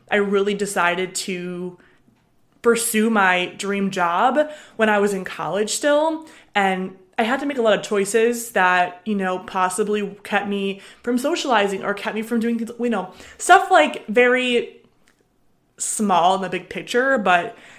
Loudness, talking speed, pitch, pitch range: -20 LUFS, 160 wpm, 205 Hz, 190-235 Hz